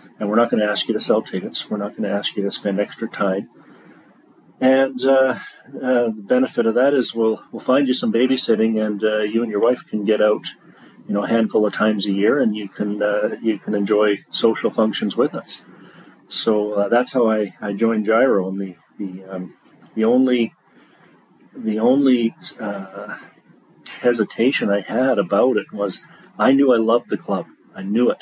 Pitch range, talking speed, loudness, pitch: 105-120 Hz, 200 wpm, -19 LUFS, 110 Hz